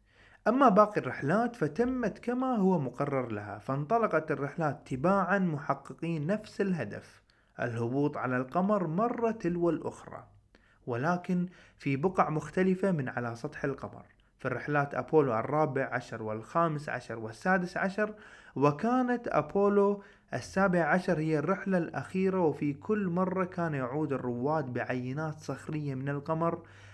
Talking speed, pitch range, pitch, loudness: 120 wpm, 130-190 Hz, 155 Hz, -31 LUFS